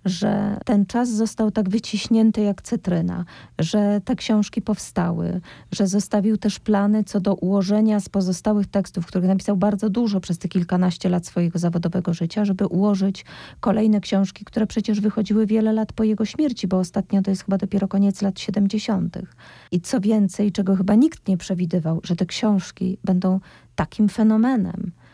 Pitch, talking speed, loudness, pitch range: 200 Hz, 160 wpm, -21 LUFS, 185-215 Hz